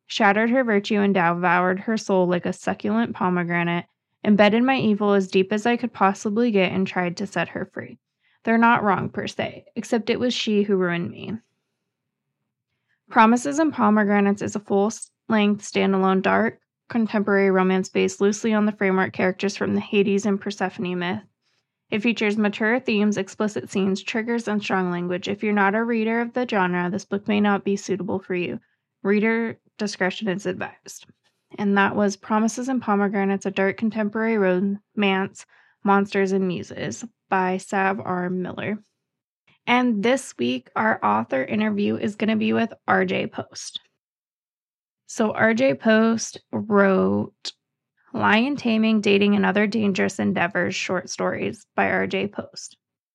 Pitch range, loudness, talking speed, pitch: 190-220 Hz, -22 LUFS, 160 wpm, 200 Hz